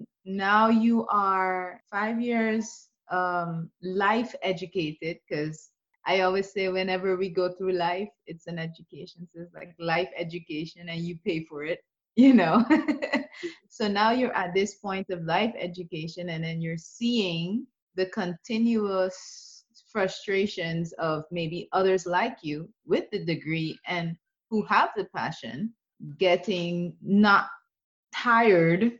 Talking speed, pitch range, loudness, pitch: 130 wpm, 175-220 Hz, -27 LUFS, 190 Hz